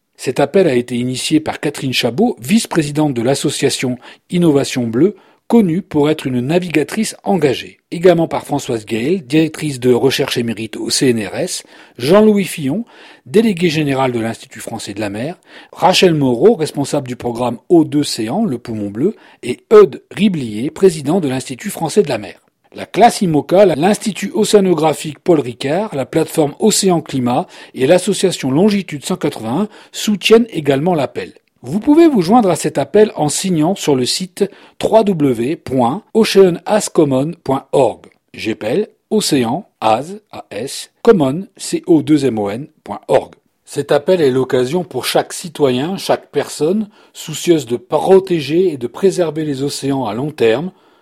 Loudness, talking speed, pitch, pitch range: -15 LUFS, 140 wpm, 155 Hz, 130-190 Hz